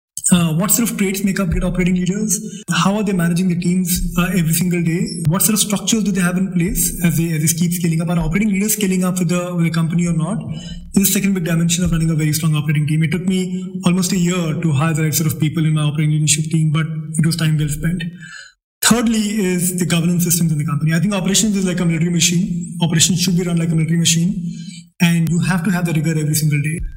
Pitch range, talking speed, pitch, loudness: 165-185 Hz, 260 wpm, 175 Hz, -17 LUFS